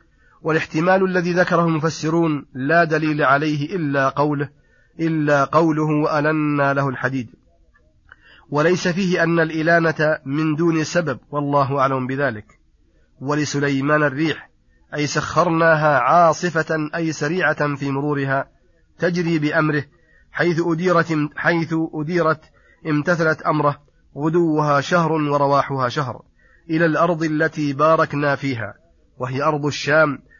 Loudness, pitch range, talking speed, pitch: -19 LUFS, 140-165 Hz, 105 wpm, 155 Hz